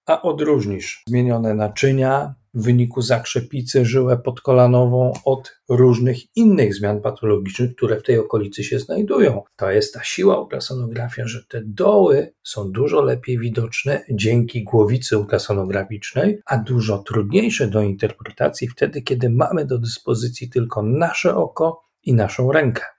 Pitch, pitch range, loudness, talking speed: 125 Hz, 115-135 Hz, -19 LUFS, 135 wpm